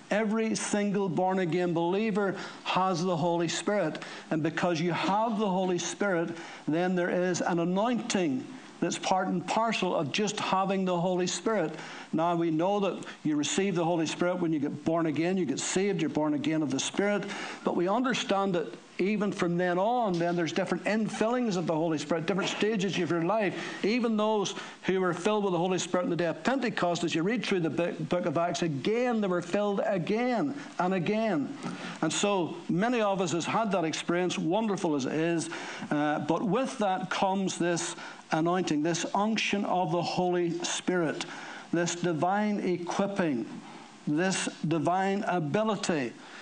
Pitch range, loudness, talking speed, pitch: 170-205 Hz, -29 LUFS, 175 wpm, 180 Hz